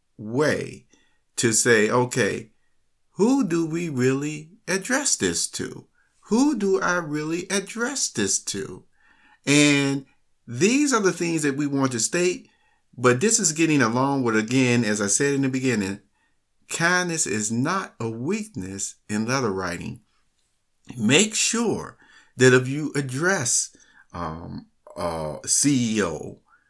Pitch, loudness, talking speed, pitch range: 145 Hz, -22 LUFS, 135 wpm, 125-190 Hz